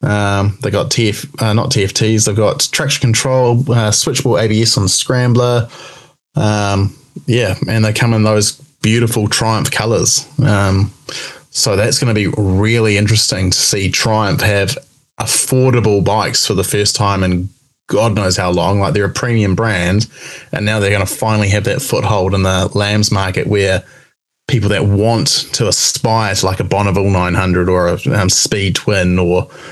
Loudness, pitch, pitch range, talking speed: -13 LUFS, 110 Hz, 100-125 Hz, 170 wpm